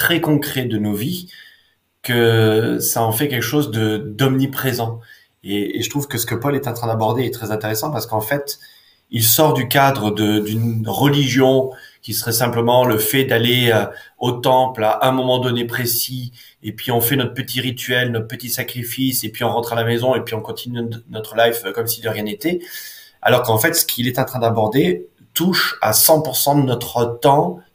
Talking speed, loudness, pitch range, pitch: 205 wpm, -18 LUFS, 115-135 Hz, 120 Hz